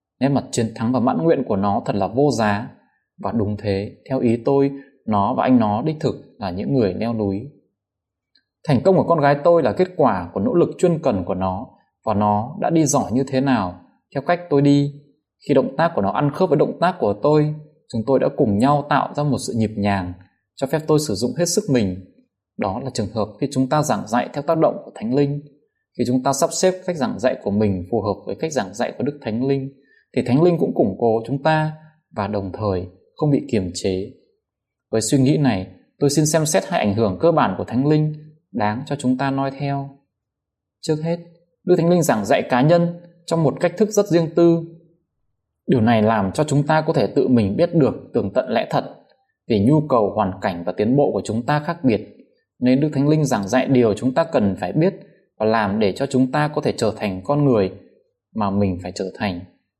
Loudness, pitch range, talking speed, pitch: -20 LUFS, 105-155 Hz, 235 wpm, 135 Hz